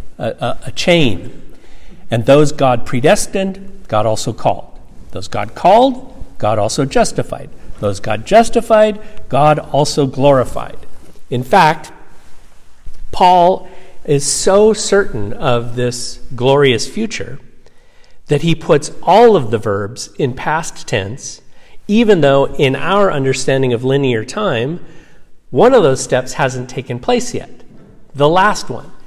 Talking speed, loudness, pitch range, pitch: 125 wpm, -14 LUFS, 120-180 Hz, 140 Hz